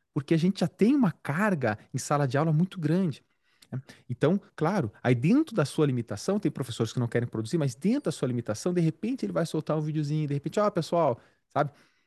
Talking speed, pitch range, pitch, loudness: 225 wpm, 130-180 Hz, 155 Hz, -28 LUFS